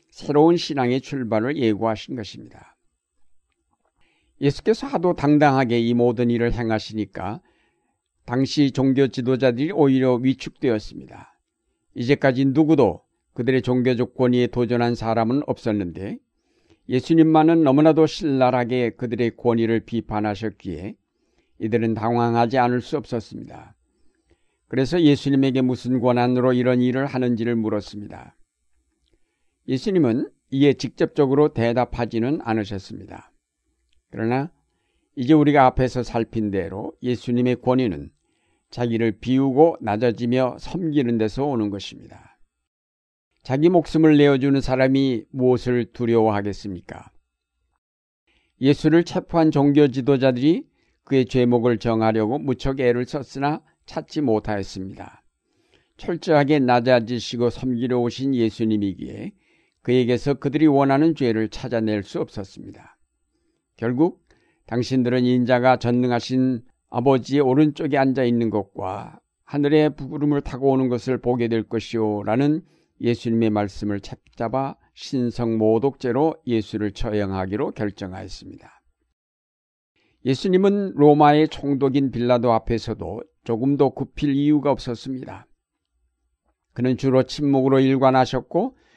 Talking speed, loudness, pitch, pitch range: 295 characters per minute, -21 LUFS, 125 Hz, 110-135 Hz